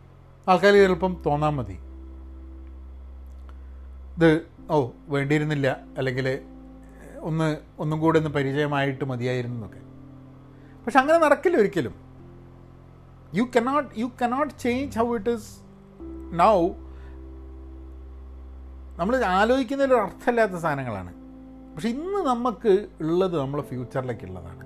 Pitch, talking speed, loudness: 135 Hz, 90 wpm, -24 LUFS